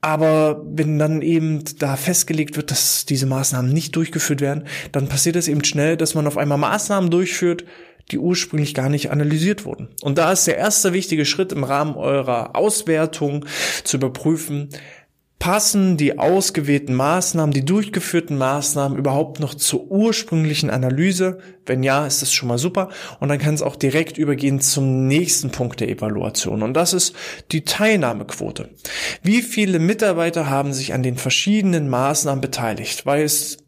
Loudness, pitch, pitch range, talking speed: -19 LUFS, 150 Hz, 140-175 Hz, 160 wpm